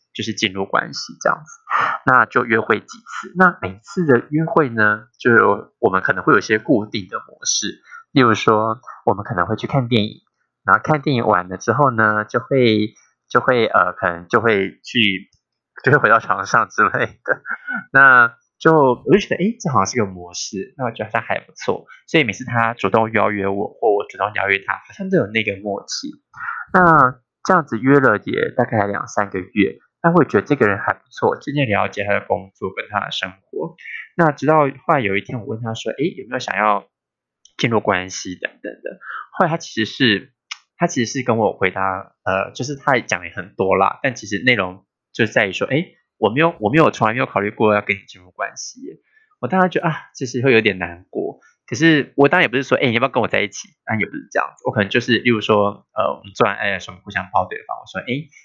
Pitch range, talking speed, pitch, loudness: 100-140 Hz, 310 characters per minute, 115 Hz, -18 LUFS